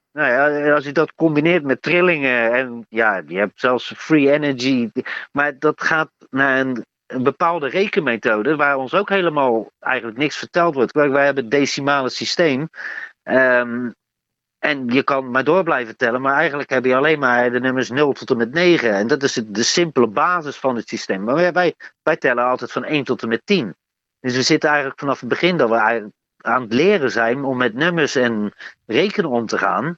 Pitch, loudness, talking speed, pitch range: 135 Hz, -18 LUFS, 200 wpm, 125-150 Hz